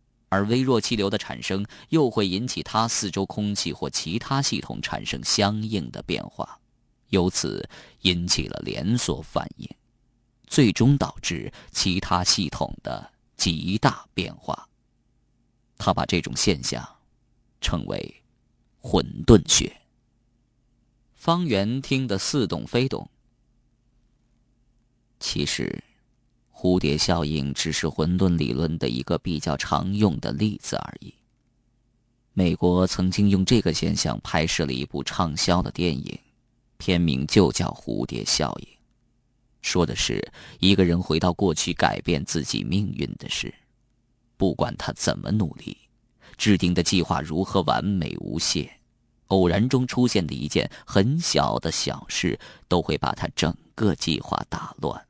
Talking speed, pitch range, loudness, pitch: 195 characters per minute, 90-120 Hz, -24 LUFS, 105 Hz